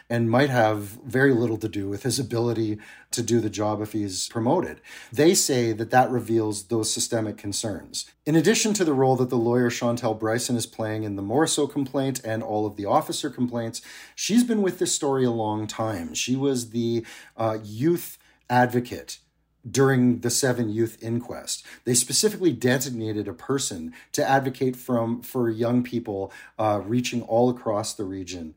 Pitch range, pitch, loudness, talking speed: 110-135 Hz, 120 Hz, -24 LUFS, 175 wpm